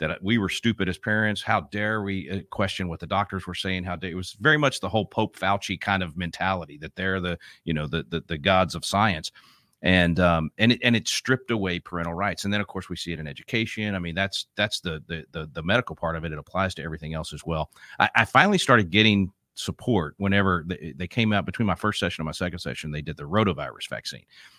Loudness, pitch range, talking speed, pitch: -25 LUFS, 85-105 Hz, 245 wpm, 95 Hz